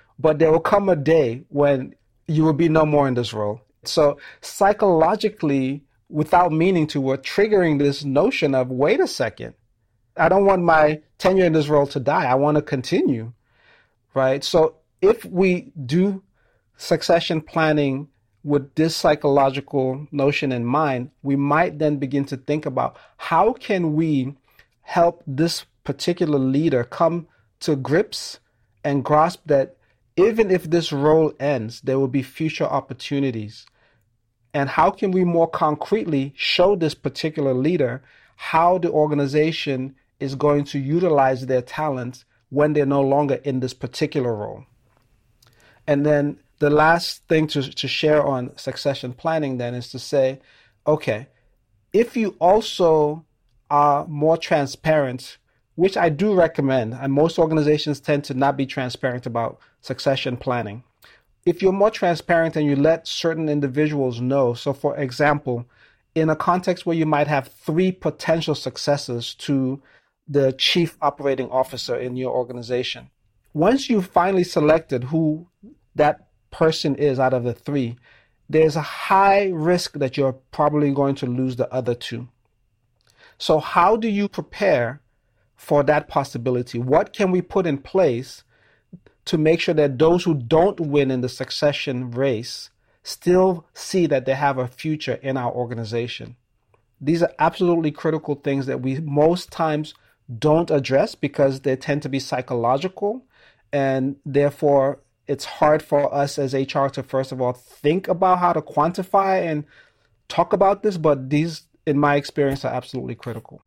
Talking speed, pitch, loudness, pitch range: 150 wpm, 145 Hz, -21 LUFS, 130-160 Hz